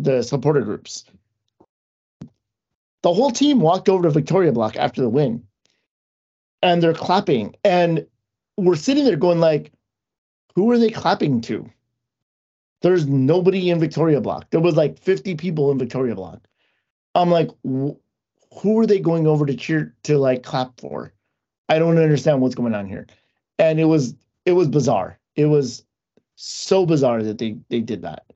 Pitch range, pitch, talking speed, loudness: 125-175 Hz, 150 Hz, 160 wpm, -19 LUFS